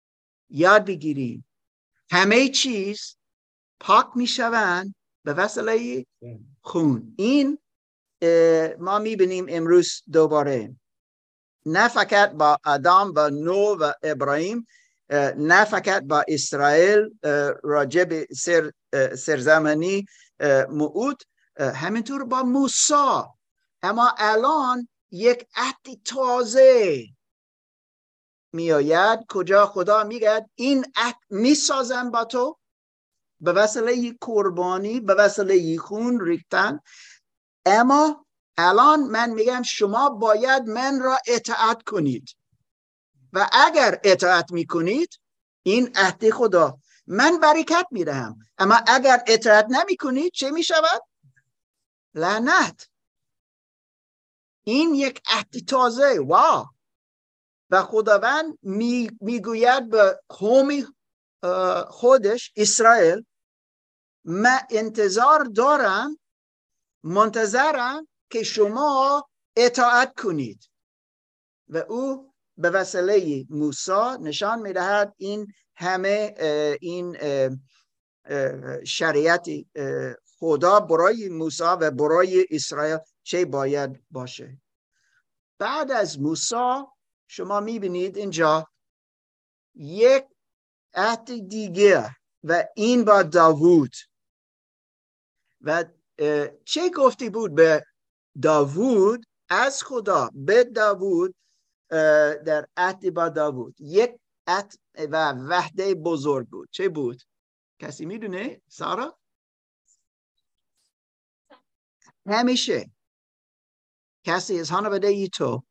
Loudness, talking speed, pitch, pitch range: -21 LUFS, 90 wpm, 205 Hz, 155-245 Hz